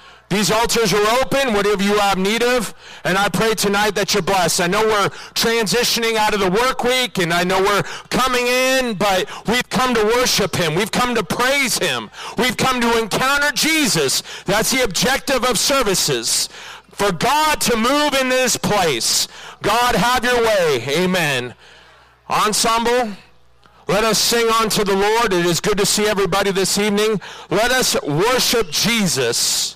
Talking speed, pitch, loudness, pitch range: 165 wpm, 220 Hz, -17 LUFS, 200-245 Hz